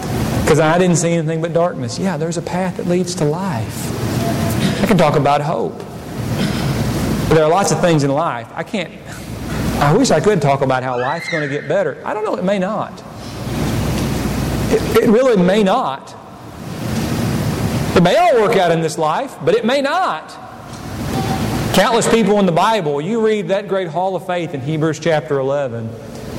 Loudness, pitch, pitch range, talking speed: -16 LUFS, 165 Hz, 140-185 Hz, 185 wpm